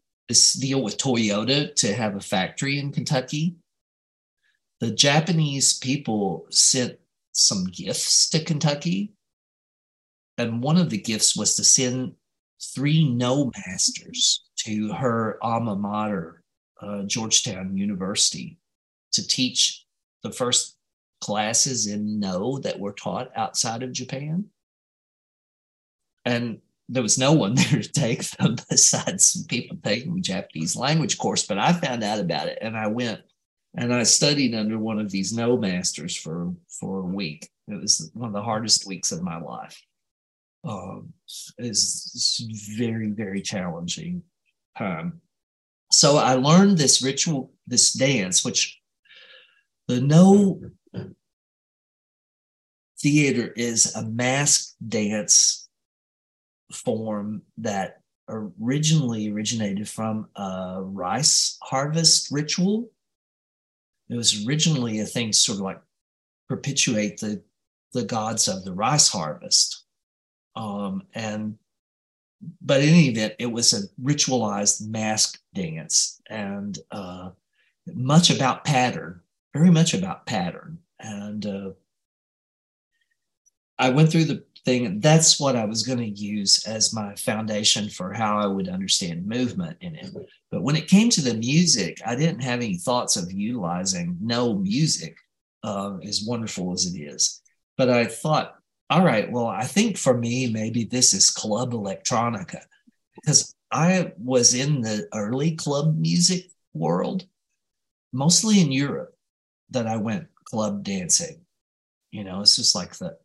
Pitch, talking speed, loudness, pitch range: 125 Hz, 135 wpm, -22 LUFS, 105-165 Hz